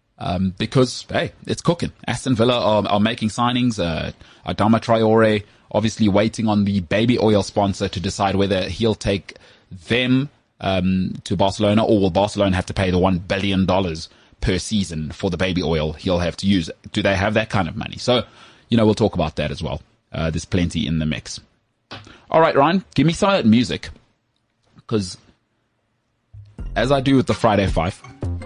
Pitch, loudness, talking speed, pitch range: 105 Hz, -20 LUFS, 180 wpm, 95-115 Hz